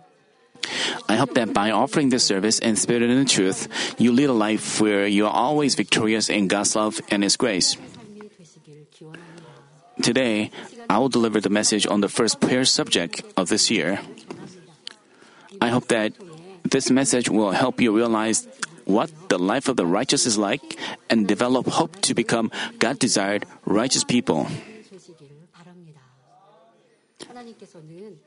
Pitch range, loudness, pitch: 110-160 Hz, -21 LUFS, 125 Hz